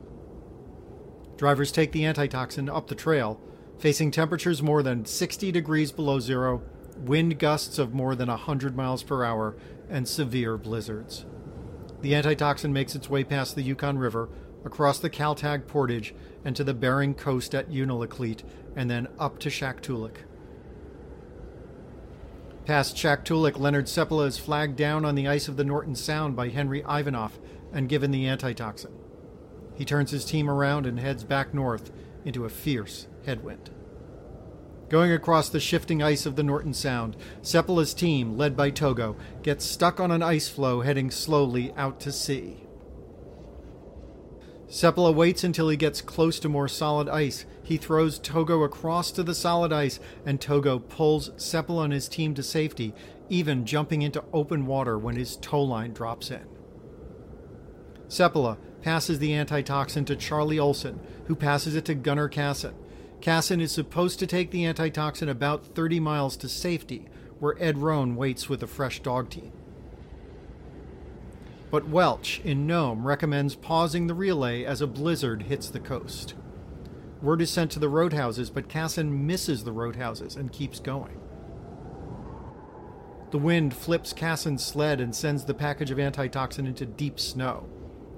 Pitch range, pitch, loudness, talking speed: 130-155 Hz, 145 Hz, -27 LUFS, 150 wpm